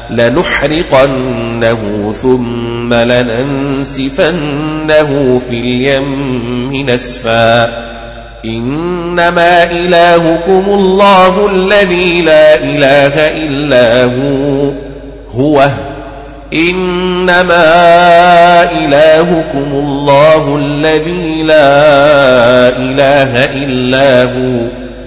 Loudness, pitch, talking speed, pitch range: -8 LUFS, 140 Hz, 55 wpm, 125-165 Hz